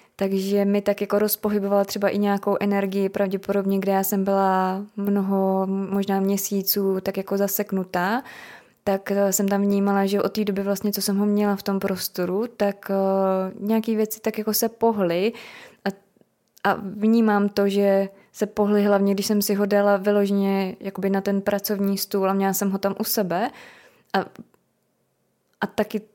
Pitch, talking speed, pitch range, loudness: 200 Hz, 165 wpm, 195-205 Hz, -23 LUFS